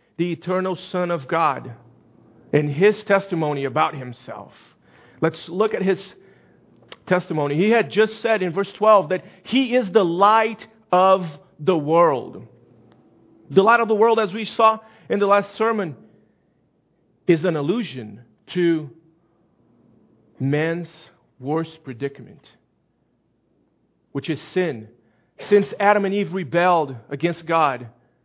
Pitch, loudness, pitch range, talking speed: 170 Hz, -20 LUFS, 140-200 Hz, 125 wpm